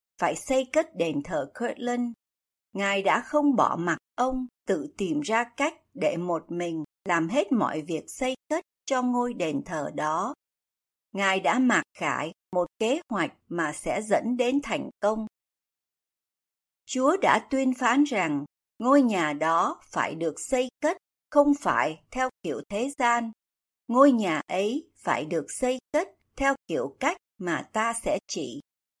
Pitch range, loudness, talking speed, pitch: 190-280 Hz, -27 LUFS, 155 wpm, 245 Hz